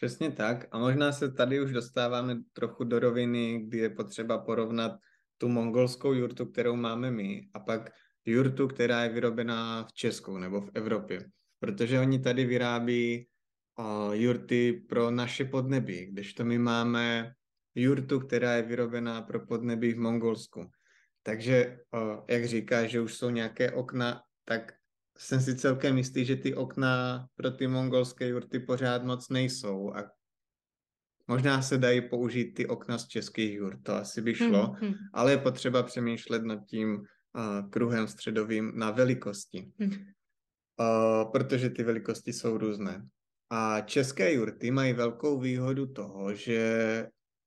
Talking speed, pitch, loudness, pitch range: 145 wpm, 120 Hz, -30 LUFS, 115-130 Hz